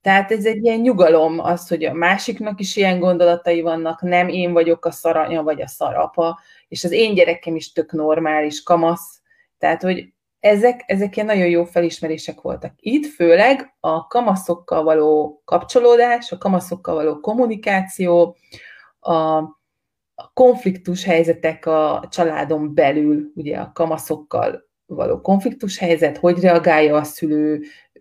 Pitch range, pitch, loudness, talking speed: 160-195 Hz, 170 Hz, -18 LUFS, 135 wpm